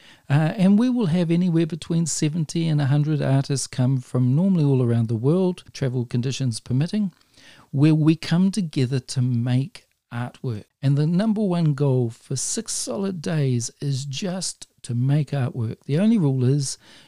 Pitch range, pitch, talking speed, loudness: 130-170 Hz, 145 Hz, 160 wpm, -22 LUFS